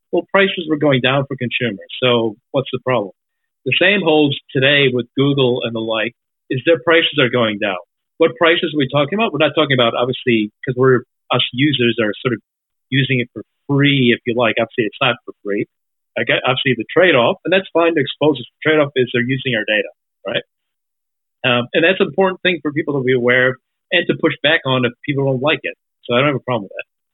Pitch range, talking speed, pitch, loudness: 120-155 Hz, 230 wpm, 135 Hz, -16 LUFS